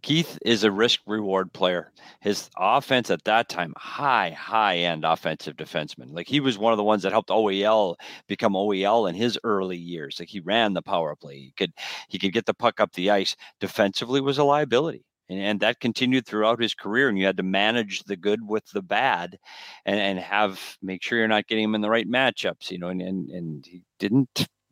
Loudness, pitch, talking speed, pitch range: -24 LUFS, 105 Hz, 215 wpm, 95-115 Hz